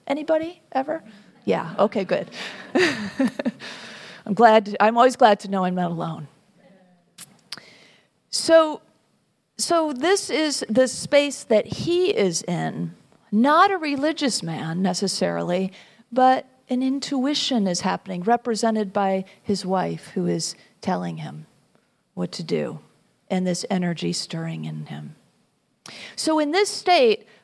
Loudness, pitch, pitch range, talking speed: -22 LUFS, 220 Hz, 180-285 Hz, 125 wpm